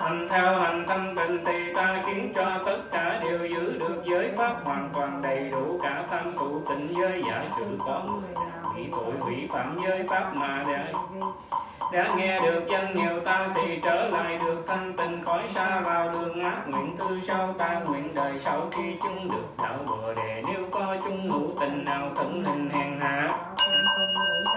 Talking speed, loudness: 190 wpm, -27 LUFS